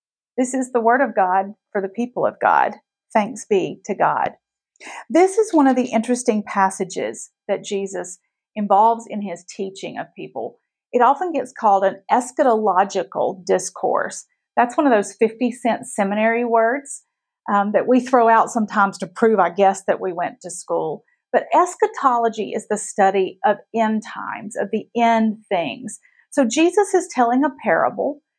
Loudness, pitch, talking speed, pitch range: -19 LUFS, 225 Hz, 165 wpm, 200-255 Hz